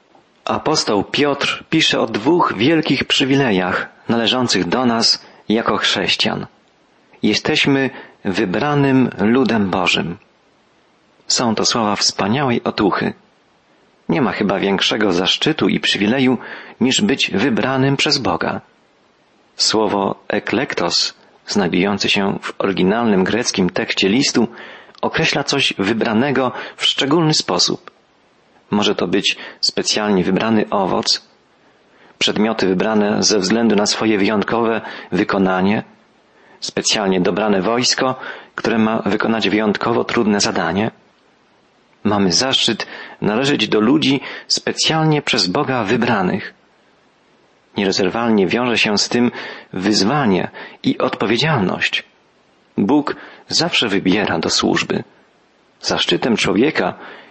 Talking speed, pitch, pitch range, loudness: 100 wpm, 120 Hz, 110-140 Hz, -16 LUFS